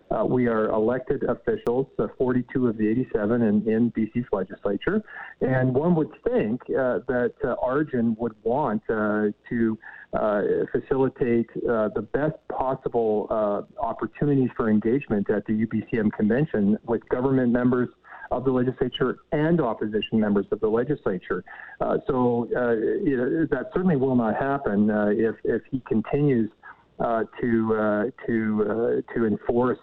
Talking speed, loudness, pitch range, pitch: 145 wpm, -25 LUFS, 110-135 Hz, 120 Hz